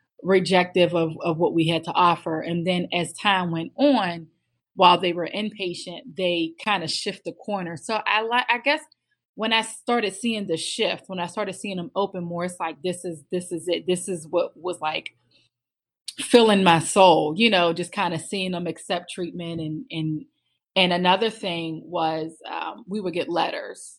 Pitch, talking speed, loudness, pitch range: 180 Hz, 195 wpm, -23 LUFS, 165-200 Hz